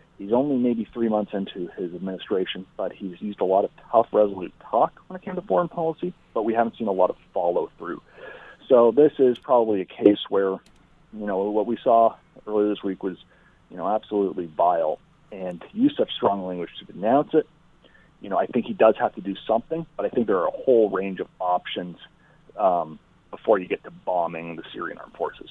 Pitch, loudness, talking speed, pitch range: 105 Hz, -24 LUFS, 210 wpm, 95-125 Hz